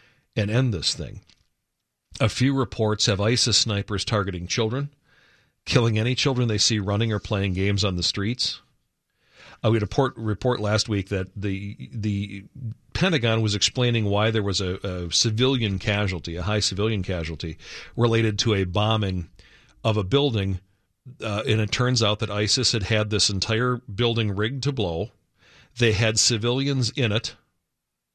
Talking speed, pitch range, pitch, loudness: 160 wpm, 100-120 Hz, 110 Hz, -23 LUFS